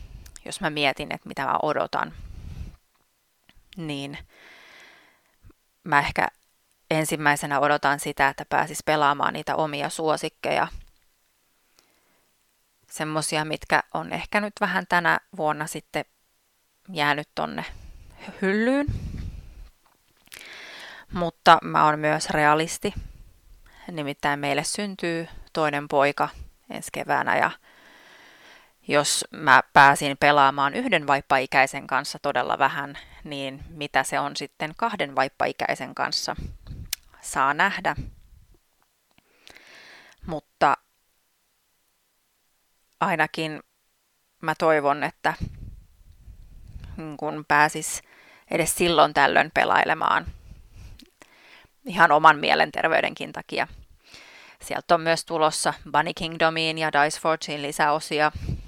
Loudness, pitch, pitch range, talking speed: -23 LUFS, 150 Hz, 140-170 Hz, 90 wpm